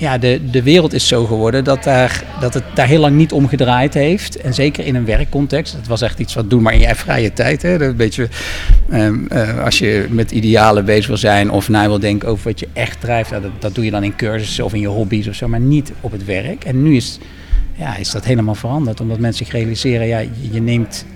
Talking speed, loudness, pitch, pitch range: 255 wpm, -15 LUFS, 115 Hz, 105-130 Hz